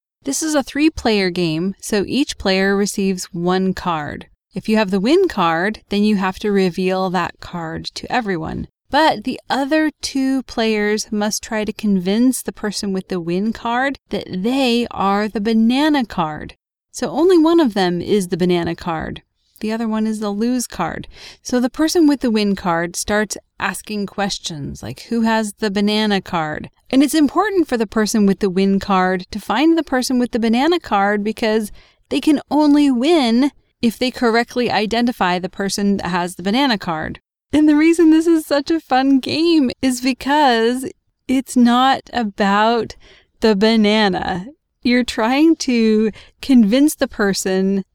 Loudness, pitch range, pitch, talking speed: -17 LUFS, 195-265 Hz, 220 Hz, 170 wpm